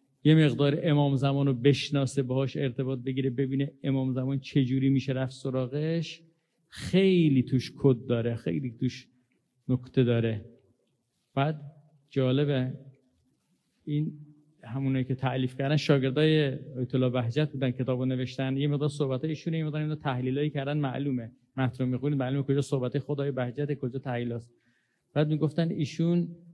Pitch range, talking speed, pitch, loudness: 130-150 Hz, 135 wpm, 135 Hz, -28 LUFS